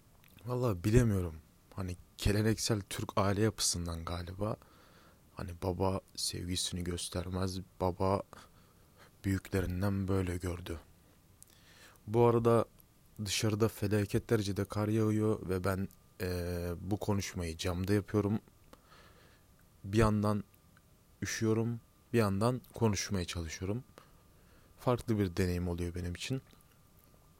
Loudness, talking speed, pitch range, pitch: -34 LUFS, 95 wpm, 90-110 Hz, 95 Hz